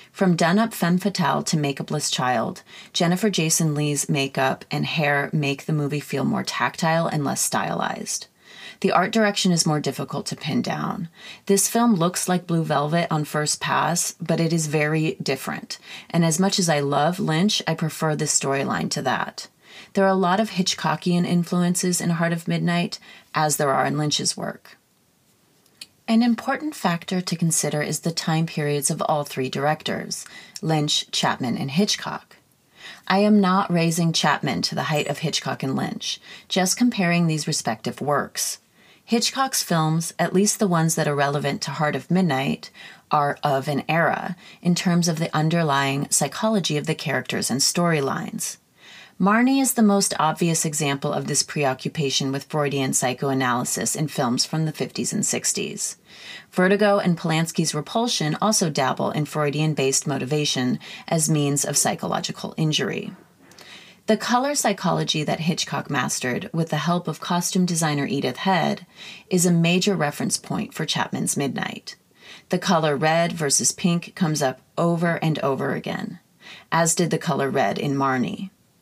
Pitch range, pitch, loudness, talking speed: 150-195 Hz, 170 Hz, -22 LUFS, 160 wpm